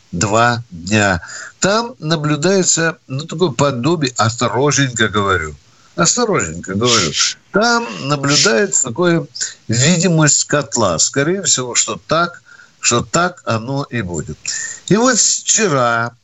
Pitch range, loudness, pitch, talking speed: 115-170 Hz, -15 LUFS, 135 Hz, 105 wpm